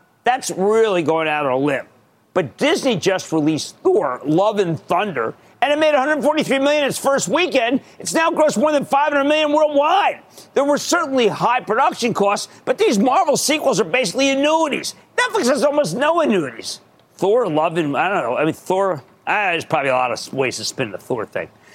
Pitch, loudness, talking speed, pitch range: 275 Hz, -18 LUFS, 195 wpm, 205-305 Hz